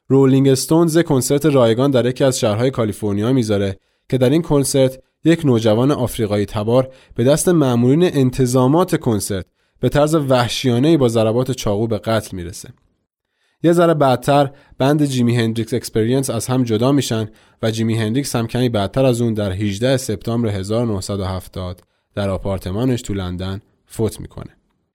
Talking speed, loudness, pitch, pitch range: 145 wpm, -17 LUFS, 125 Hz, 105-135 Hz